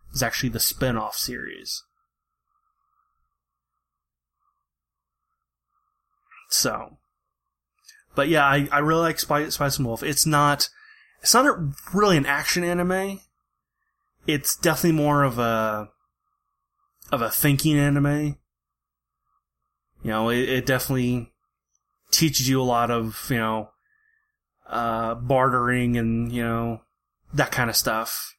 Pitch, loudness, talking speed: 150 Hz, -22 LUFS, 115 wpm